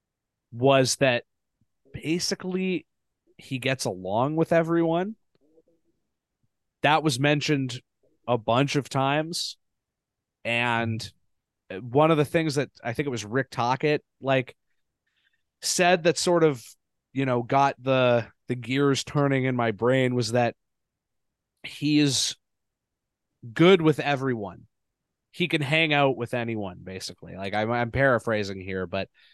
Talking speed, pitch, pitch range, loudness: 130 wpm, 135 Hz, 120-150 Hz, -24 LUFS